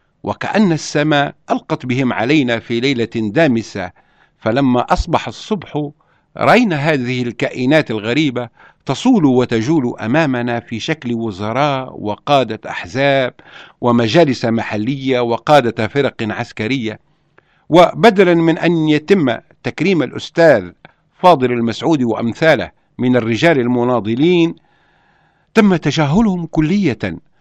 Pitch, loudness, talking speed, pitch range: 135 Hz, -15 LUFS, 95 wpm, 115-160 Hz